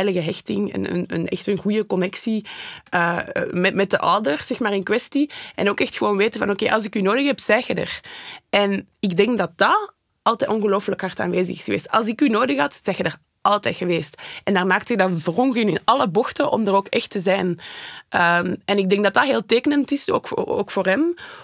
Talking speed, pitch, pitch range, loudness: 230 wpm, 200 Hz, 185-230 Hz, -20 LUFS